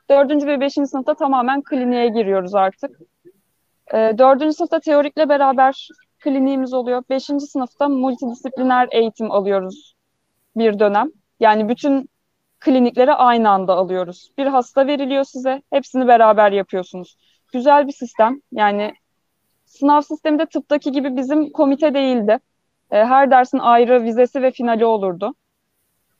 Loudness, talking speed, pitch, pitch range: -17 LUFS, 120 wpm, 265 Hz, 230-285 Hz